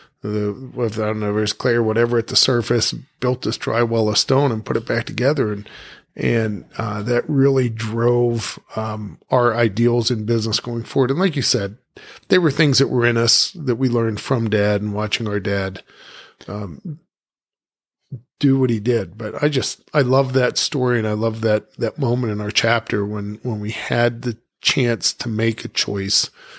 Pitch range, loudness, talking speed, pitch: 110-130 Hz, -19 LUFS, 195 wpm, 115 Hz